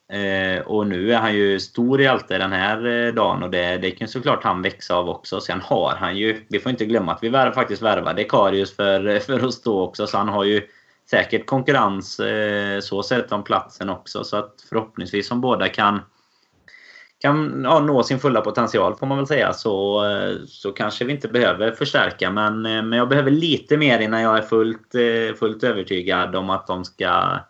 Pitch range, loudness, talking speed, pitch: 100-125 Hz, -20 LUFS, 195 wpm, 110 Hz